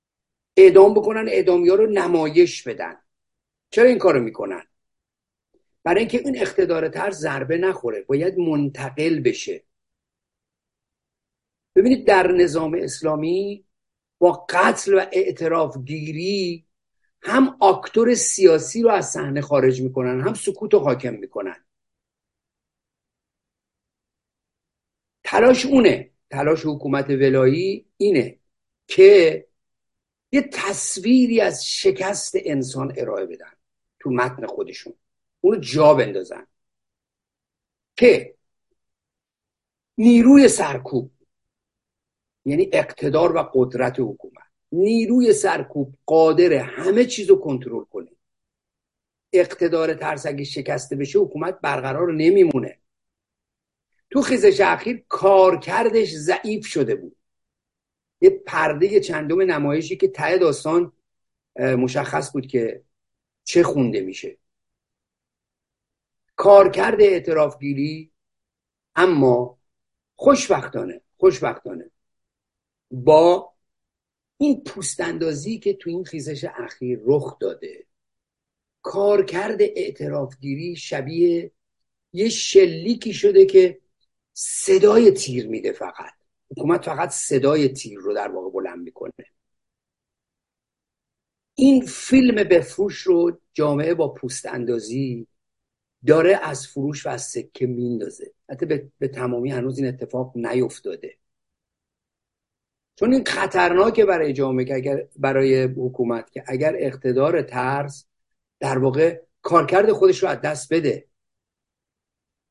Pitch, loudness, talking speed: 175 Hz, -19 LUFS, 100 wpm